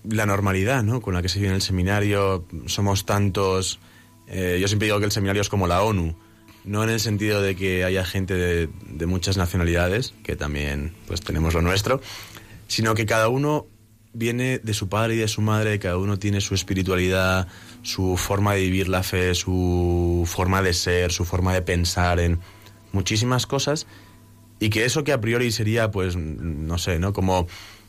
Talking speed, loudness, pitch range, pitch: 185 wpm, -23 LUFS, 90-110 Hz, 100 Hz